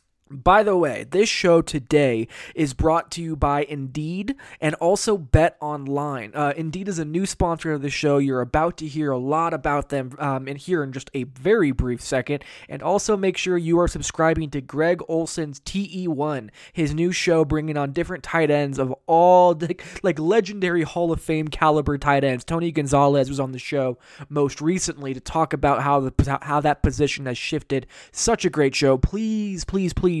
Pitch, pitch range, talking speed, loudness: 155 Hz, 140-170 Hz, 200 wpm, -22 LUFS